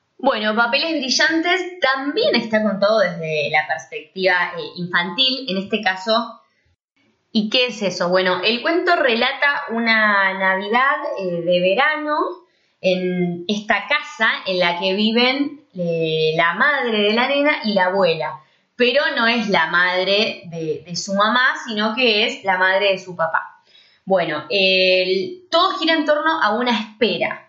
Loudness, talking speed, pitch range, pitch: -18 LUFS, 155 wpm, 185-265 Hz, 215 Hz